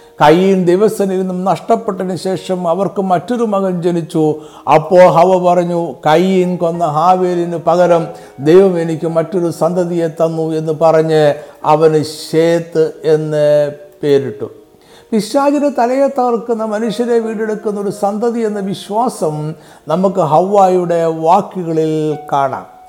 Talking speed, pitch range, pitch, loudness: 105 wpm, 160-200 Hz, 175 Hz, -13 LUFS